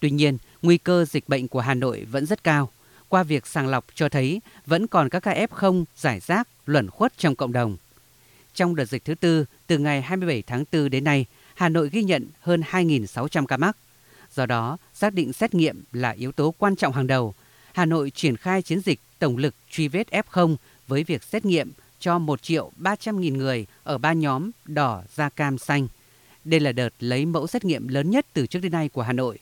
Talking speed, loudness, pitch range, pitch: 220 wpm, -24 LUFS, 130-175 Hz, 150 Hz